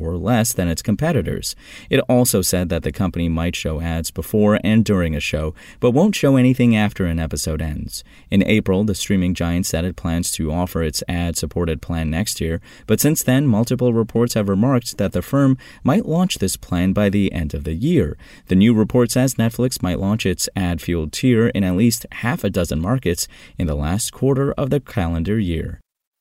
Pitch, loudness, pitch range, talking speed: 95 Hz, -19 LUFS, 85-115 Hz, 200 wpm